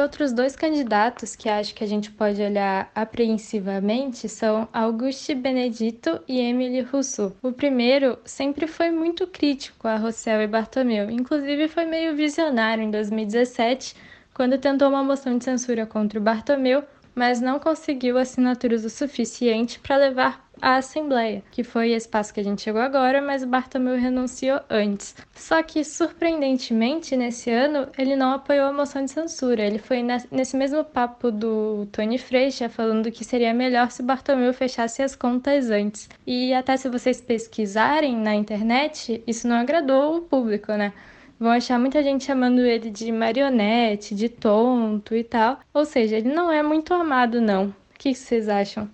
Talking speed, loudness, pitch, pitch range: 165 wpm, -23 LUFS, 250 Hz, 225-275 Hz